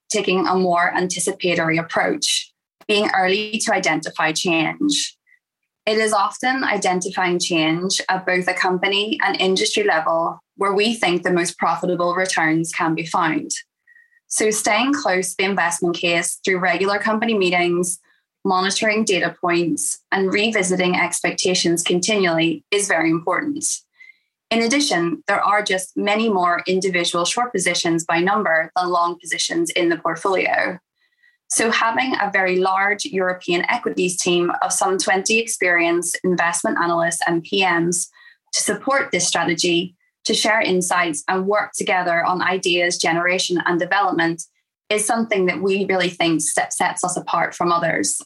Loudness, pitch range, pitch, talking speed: -19 LUFS, 175-210 Hz, 185 Hz, 140 wpm